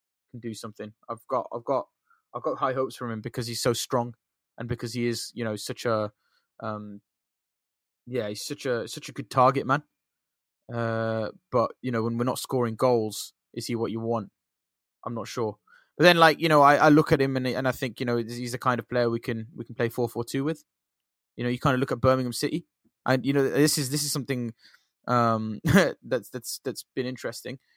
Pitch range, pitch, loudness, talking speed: 115-130 Hz, 120 Hz, -26 LUFS, 225 wpm